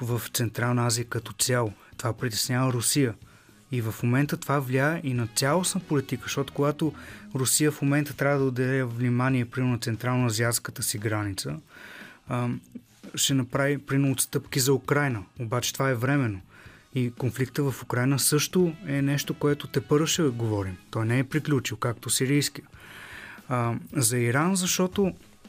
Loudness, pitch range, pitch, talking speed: -26 LUFS, 120-145 Hz, 130 Hz, 145 wpm